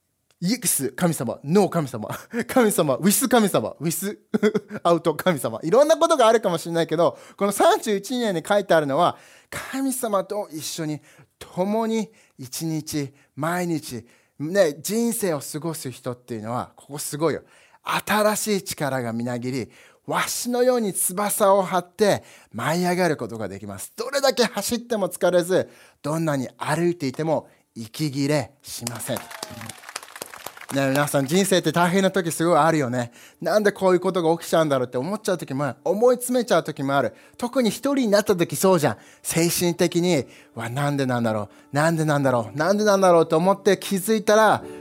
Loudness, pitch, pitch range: -22 LUFS, 170 Hz, 140-205 Hz